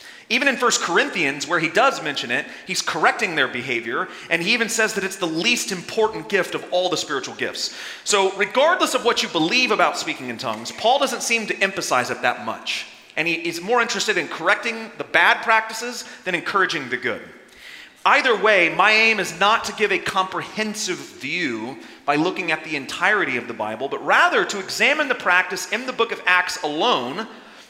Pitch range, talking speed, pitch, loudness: 180-235 Hz, 195 wpm, 215 Hz, -20 LUFS